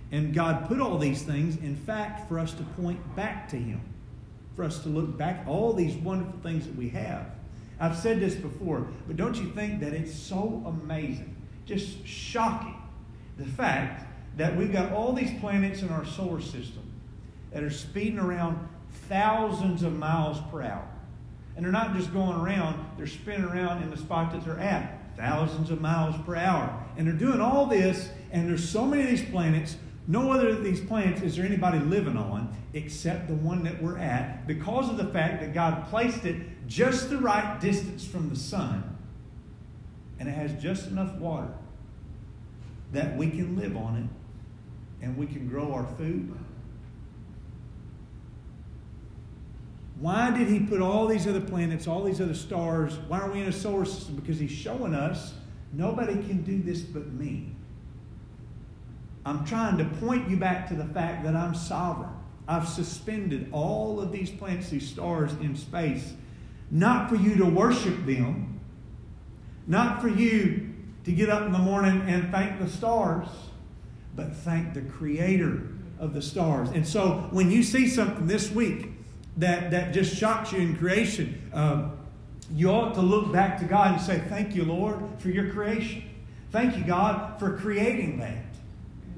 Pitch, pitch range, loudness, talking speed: 170 Hz, 150-195 Hz, -28 LUFS, 175 wpm